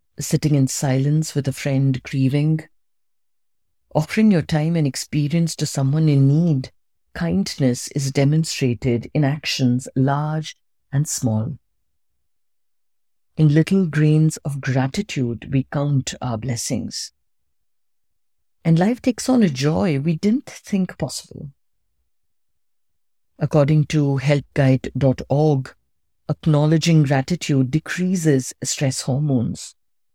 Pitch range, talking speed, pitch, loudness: 120-155 Hz, 100 wpm, 140 Hz, -20 LUFS